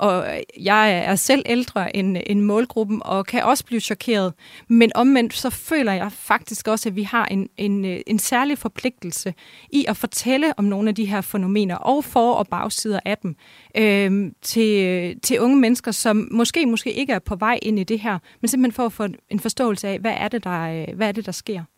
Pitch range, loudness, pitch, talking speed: 200-235 Hz, -20 LUFS, 215 Hz, 210 wpm